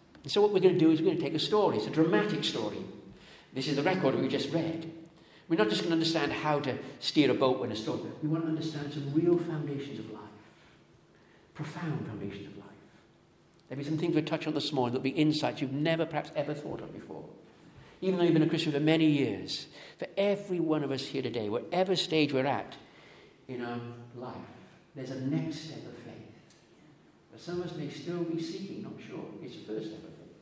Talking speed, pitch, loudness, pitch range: 225 wpm, 150 Hz, -31 LUFS, 130-165 Hz